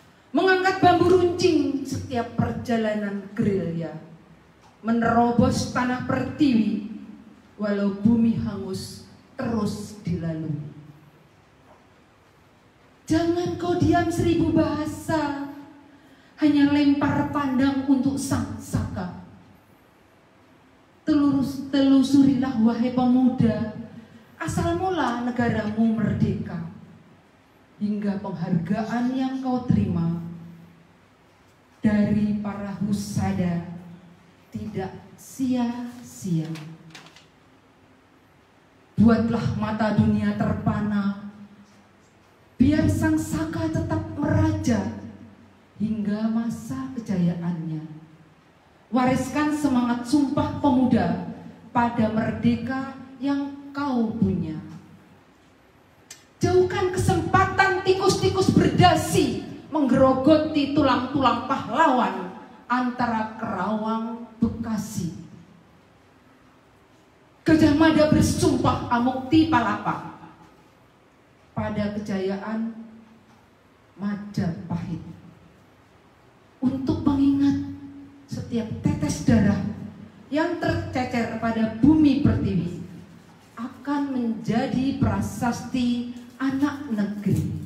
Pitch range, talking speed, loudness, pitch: 200-275 Hz, 65 wpm, -23 LUFS, 230 Hz